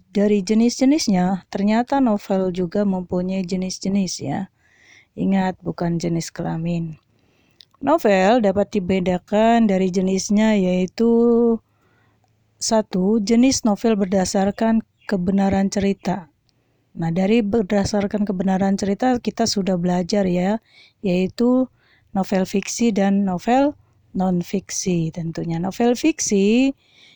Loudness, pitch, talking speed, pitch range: -20 LUFS, 195 Hz, 95 wpm, 180-220 Hz